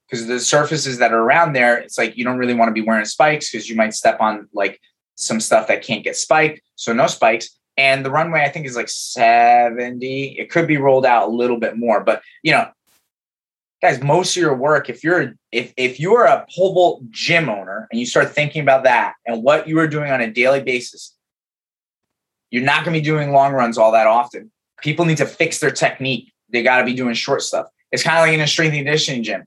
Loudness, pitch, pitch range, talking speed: -16 LUFS, 135 Hz, 120-155 Hz, 235 wpm